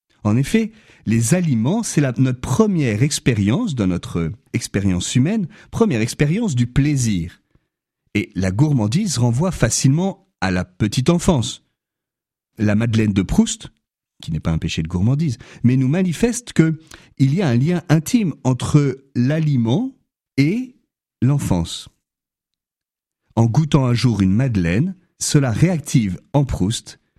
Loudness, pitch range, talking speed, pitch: -19 LUFS, 110-160 Hz, 130 wpm, 130 Hz